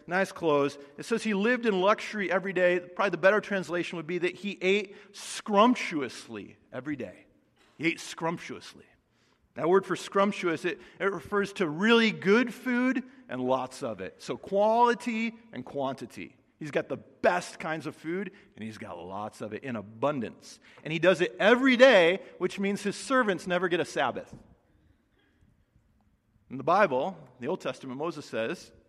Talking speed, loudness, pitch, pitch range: 170 wpm, -28 LUFS, 180 Hz, 140-205 Hz